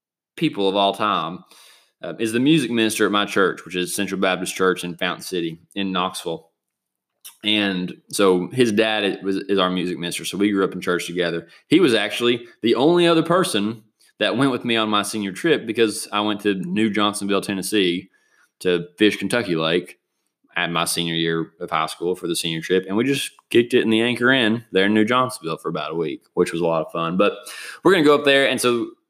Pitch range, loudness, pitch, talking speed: 90-115 Hz, -20 LUFS, 100 Hz, 220 wpm